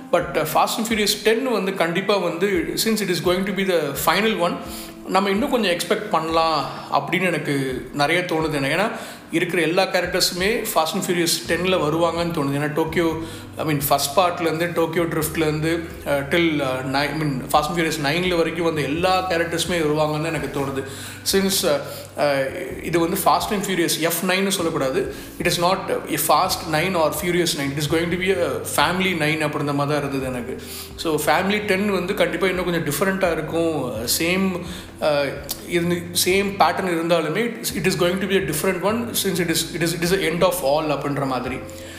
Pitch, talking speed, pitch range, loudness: 170 Hz, 175 wpm, 150-185 Hz, -21 LUFS